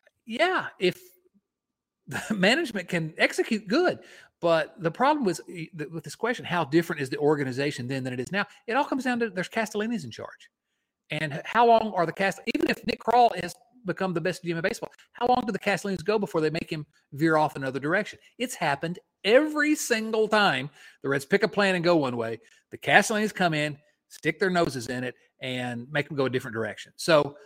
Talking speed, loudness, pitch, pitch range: 210 wpm, -26 LUFS, 180 Hz, 150-220 Hz